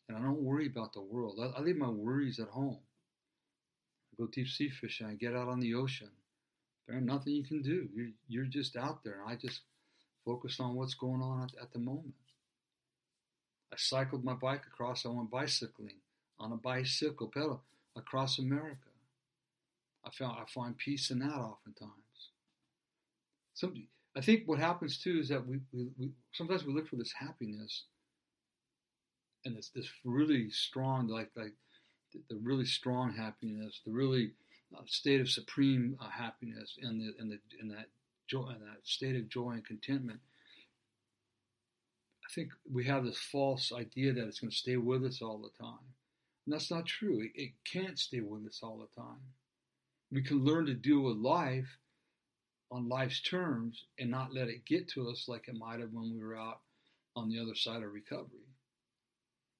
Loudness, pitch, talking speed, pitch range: -38 LUFS, 125 Hz, 175 wpm, 115-135 Hz